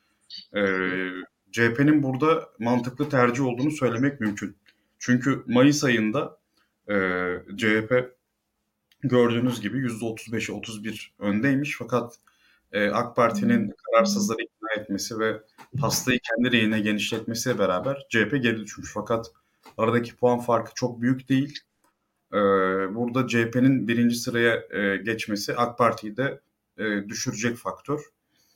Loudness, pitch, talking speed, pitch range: -25 LUFS, 115 Hz, 120 wpm, 110-125 Hz